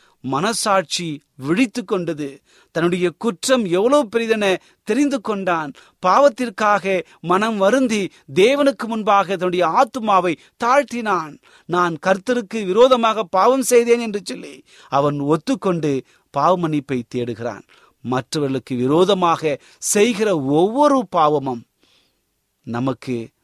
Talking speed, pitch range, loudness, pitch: 85 wpm, 155-230 Hz, -18 LUFS, 190 Hz